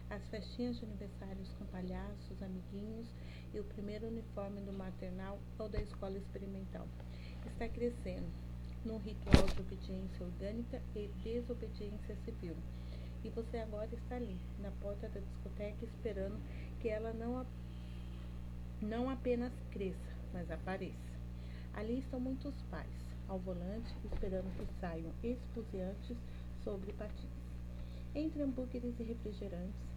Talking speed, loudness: 125 wpm, -44 LUFS